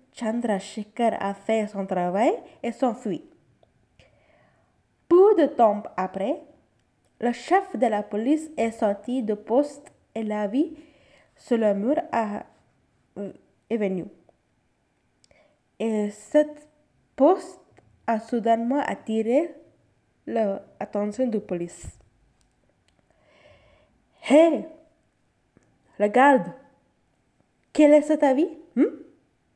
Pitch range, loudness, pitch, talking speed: 210-300 Hz, -24 LUFS, 240 Hz, 95 wpm